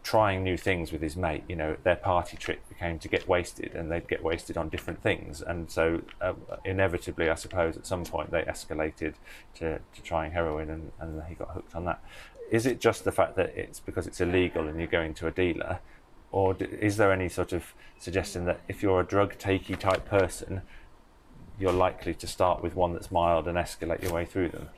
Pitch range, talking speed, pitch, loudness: 80-95 Hz, 220 wpm, 90 Hz, -30 LUFS